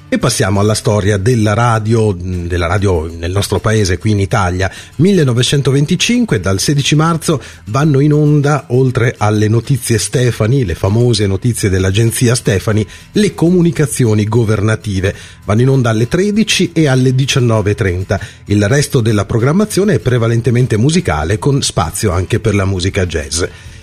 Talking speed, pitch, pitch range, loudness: 140 wpm, 115 Hz, 105-140 Hz, -13 LUFS